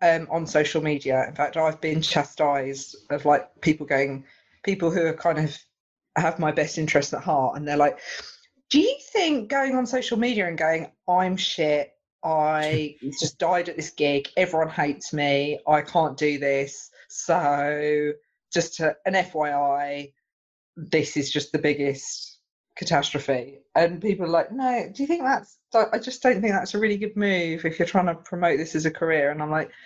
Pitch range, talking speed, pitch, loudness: 145-185 Hz, 185 wpm, 160 Hz, -24 LUFS